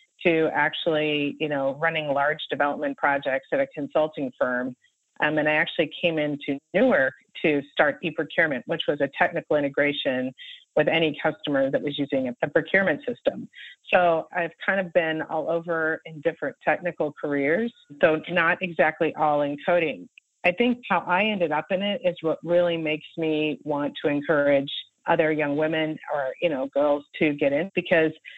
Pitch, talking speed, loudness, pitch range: 160 Hz, 170 wpm, -24 LUFS, 145-175 Hz